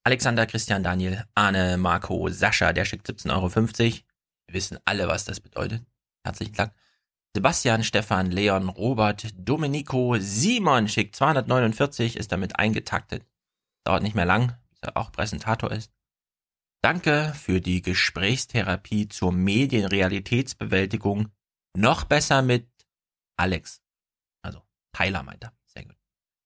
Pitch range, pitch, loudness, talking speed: 95-120 Hz, 110 Hz, -24 LUFS, 115 wpm